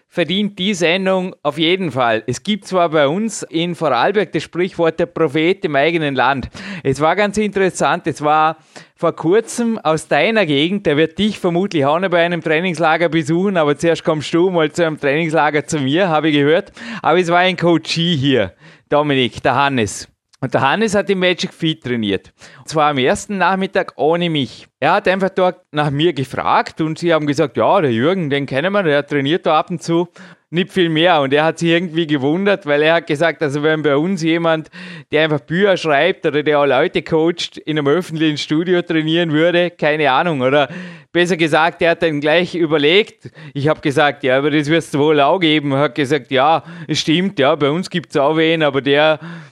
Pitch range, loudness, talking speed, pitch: 150-175 Hz, -16 LUFS, 205 wpm, 160 Hz